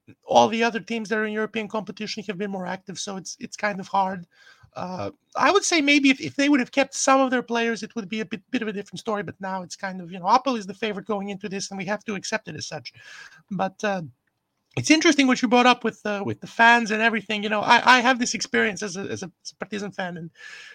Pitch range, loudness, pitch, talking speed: 195-240 Hz, -23 LUFS, 215 Hz, 280 wpm